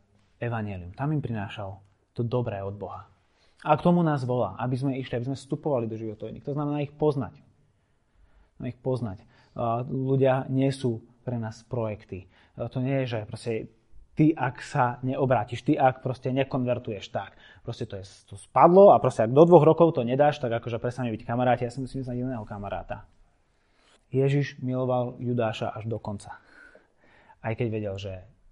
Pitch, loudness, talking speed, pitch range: 120 Hz, -26 LUFS, 180 wpm, 110-130 Hz